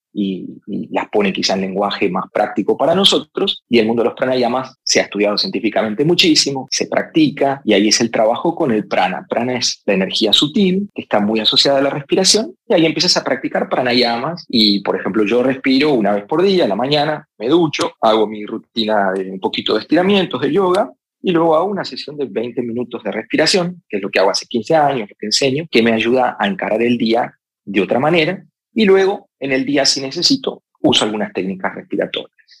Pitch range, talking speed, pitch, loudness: 110-170 Hz, 215 wpm, 130 Hz, -16 LUFS